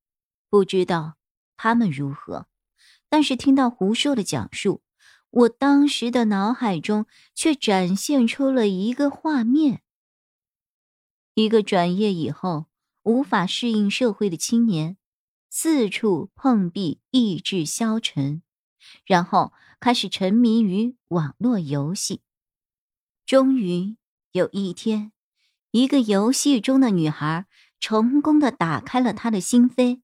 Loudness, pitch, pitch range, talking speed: -21 LUFS, 220 Hz, 180-250 Hz, 180 characters per minute